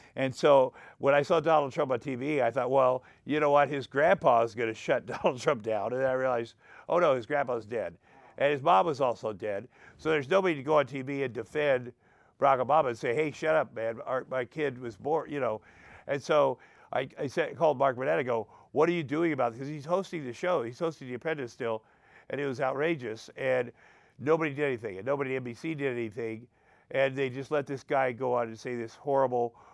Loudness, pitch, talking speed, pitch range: -29 LUFS, 135 Hz, 230 wpm, 120-150 Hz